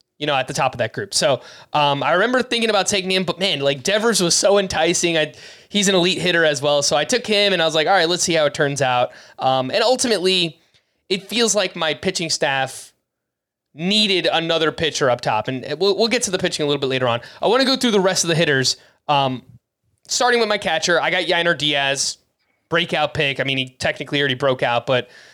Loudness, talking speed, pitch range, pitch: -18 LUFS, 240 wpm, 140-195 Hz, 165 Hz